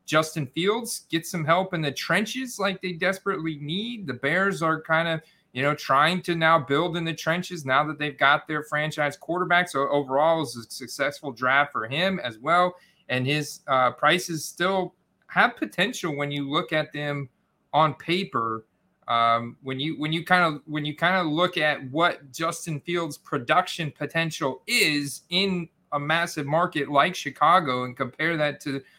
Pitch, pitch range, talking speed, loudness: 160 Hz, 145-180 Hz, 180 wpm, -25 LUFS